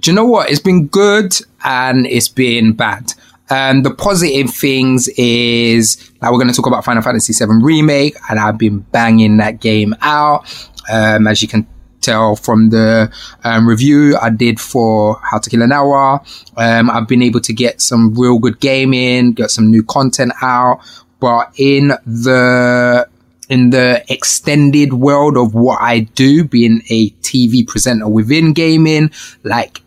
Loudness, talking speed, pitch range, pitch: -11 LUFS, 170 wpm, 115-135 Hz, 125 Hz